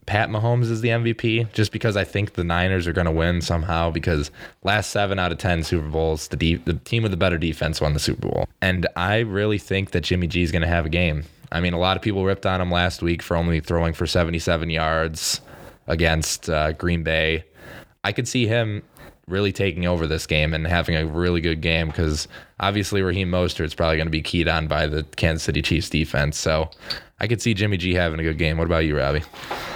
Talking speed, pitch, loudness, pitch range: 235 wpm, 85 Hz, -22 LUFS, 80-95 Hz